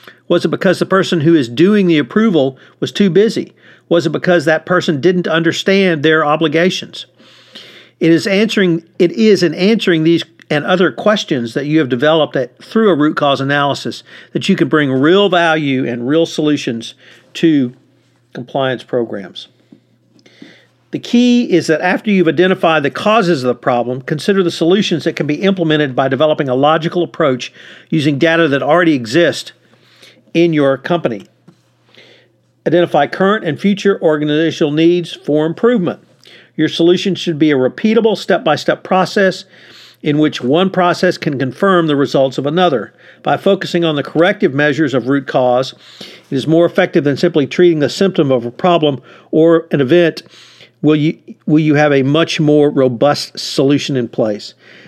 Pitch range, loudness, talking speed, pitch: 145-180 Hz, -13 LUFS, 165 wpm, 165 Hz